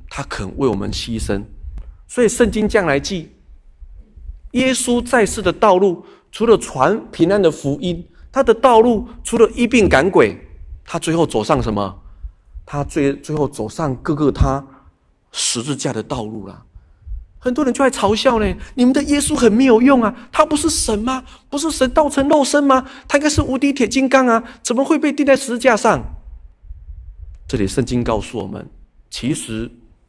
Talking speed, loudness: 245 characters per minute, -16 LUFS